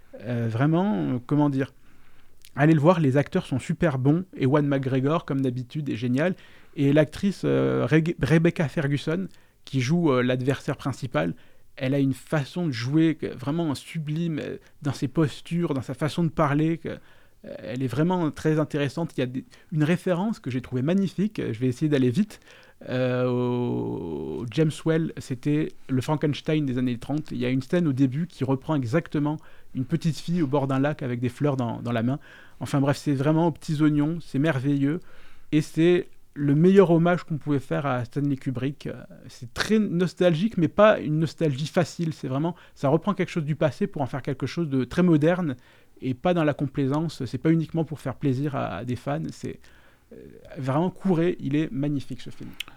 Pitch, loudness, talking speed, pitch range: 150 Hz, -25 LUFS, 195 wpm, 130-165 Hz